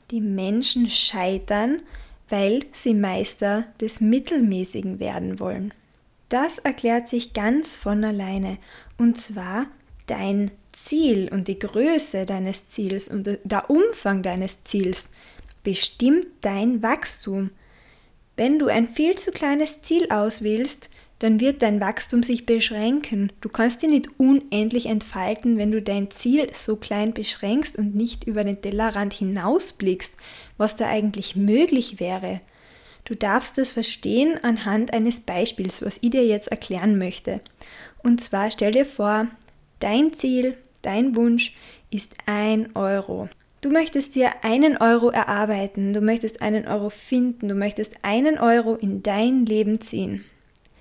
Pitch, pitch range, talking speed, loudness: 220 Hz, 200-245 Hz, 135 wpm, -22 LUFS